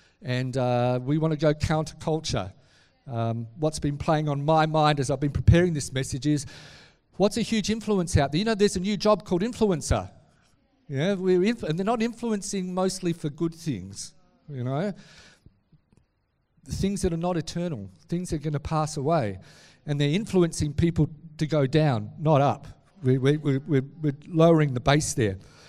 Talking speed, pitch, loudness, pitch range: 180 wpm, 155 Hz, -25 LUFS, 135-180 Hz